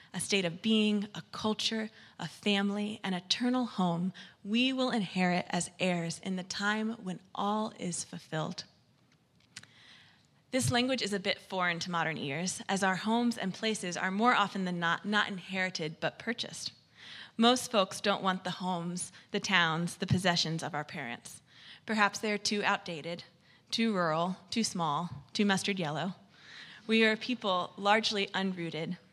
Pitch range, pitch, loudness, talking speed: 175-210 Hz, 190 Hz, -32 LUFS, 160 wpm